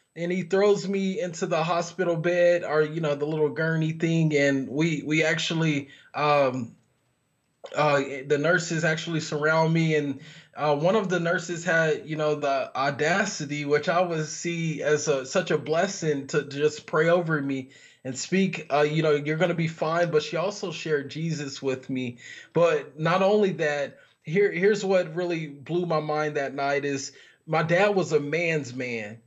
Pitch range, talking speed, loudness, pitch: 145-175 Hz, 180 wpm, -25 LUFS, 155 Hz